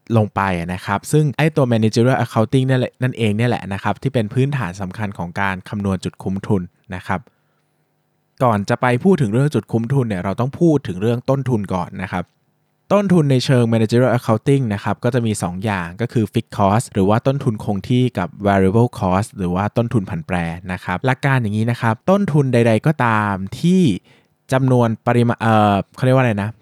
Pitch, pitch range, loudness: 115 Hz, 100-130 Hz, -18 LUFS